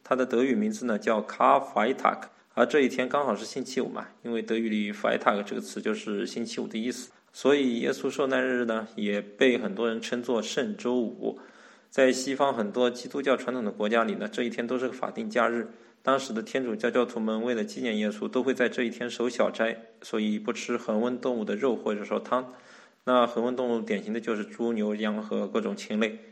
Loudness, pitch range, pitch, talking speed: -28 LUFS, 115-125 Hz, 120 Hz, 335 characters per minute